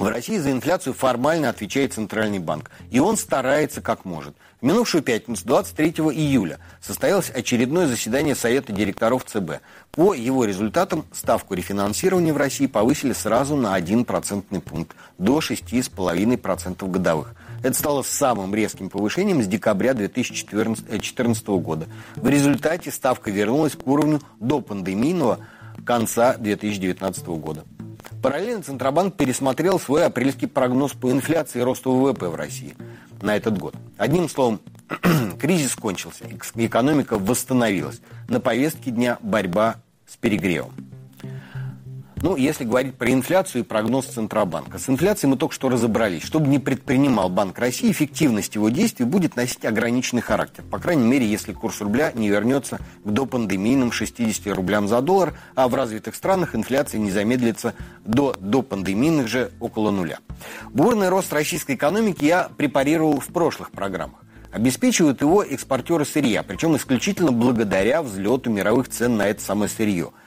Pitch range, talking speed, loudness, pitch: 105-140 Hz, 140 wpm, -21 LUFS, 120 Hz